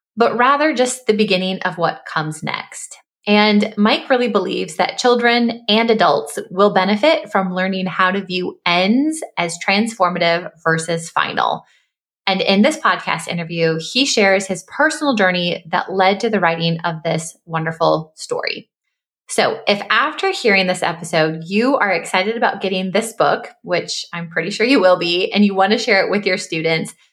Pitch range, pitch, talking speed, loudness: 170-225 Hz, 190 Hz, 170 wpm, -17 LUFS